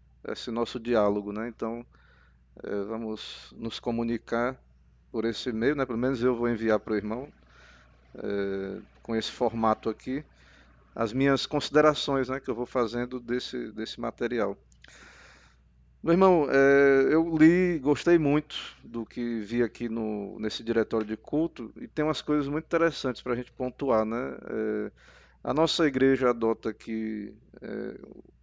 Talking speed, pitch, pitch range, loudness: 150 wpm, 120 Hz, 110-135 Hz, -28 LUFS